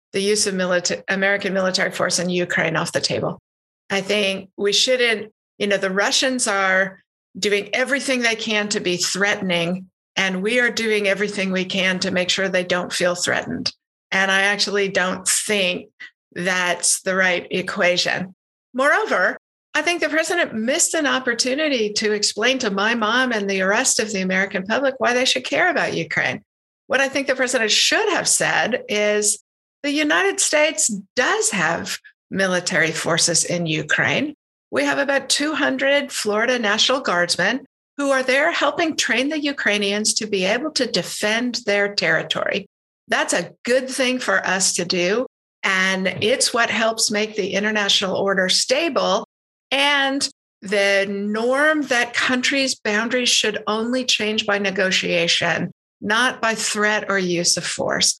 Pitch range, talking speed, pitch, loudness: 190-260 Hz, 155 wpm, 210 Hz, -19 LUFS